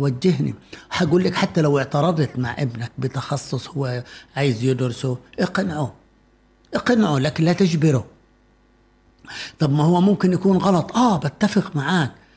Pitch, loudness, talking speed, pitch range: 150 Hz, -20 LUFS, 125 wpm, 130-180 Hz